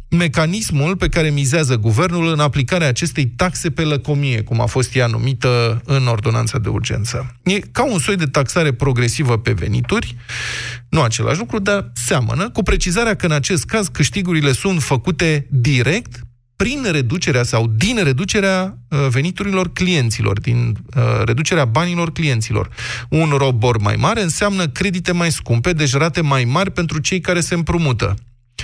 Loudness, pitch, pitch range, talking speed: -17 LUFS, 145 Hz, 120-175 Hz, 150 wpm